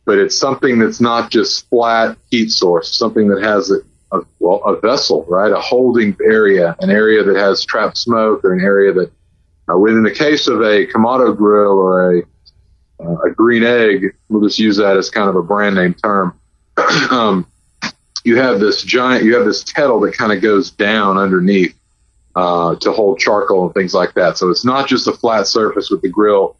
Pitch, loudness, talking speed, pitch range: 105 Hz, -13 LUFS, 200 wpm, 95-120 Hz